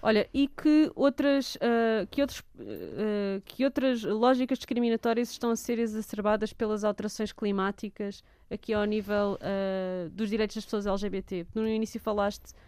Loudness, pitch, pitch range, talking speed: -29 LUFS, 220 Hz, 205-240 Hz, 145 wpm